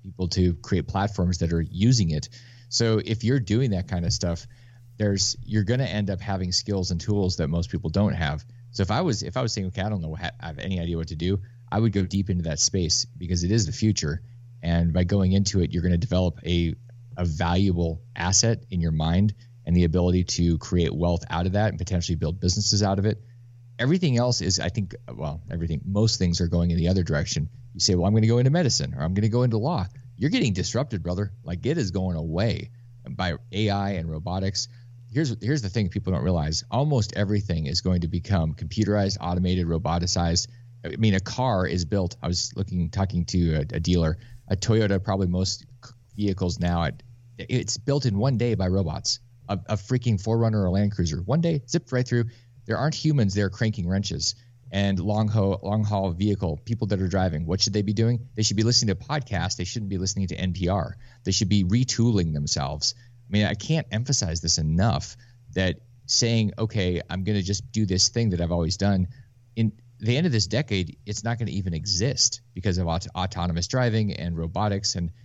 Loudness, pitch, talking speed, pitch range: -25 LUFS, 100 Hz, 220 wpm, 90-115 Hz